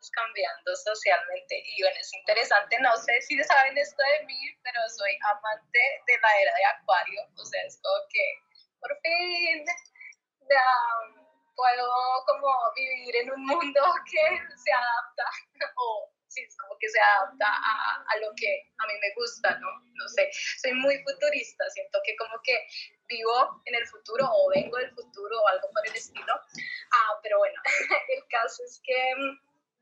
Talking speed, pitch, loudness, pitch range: 170 wpm, 275 Hz, -26 LUFS, 230-300 Hz